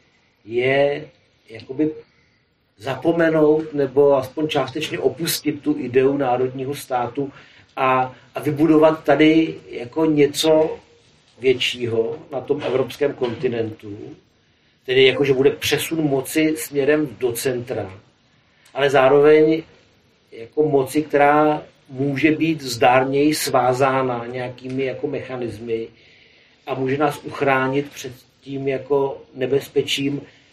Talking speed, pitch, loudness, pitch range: 100 wpm, 140 Hz, -19 LUFS, 130-155 Hz